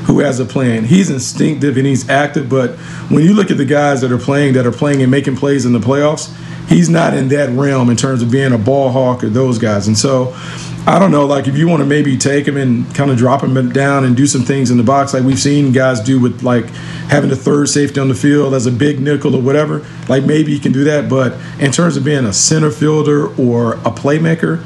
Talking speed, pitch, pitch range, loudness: 260 wpm, 140 Hz, 130-145 Hz, -12 LUFS